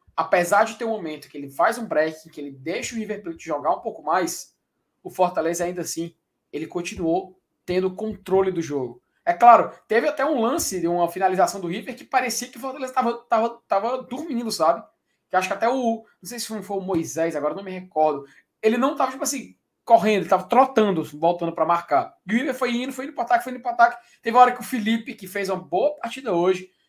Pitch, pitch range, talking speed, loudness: 205 Hz, 170-245 Hz, 230 wpm, -23 LUFS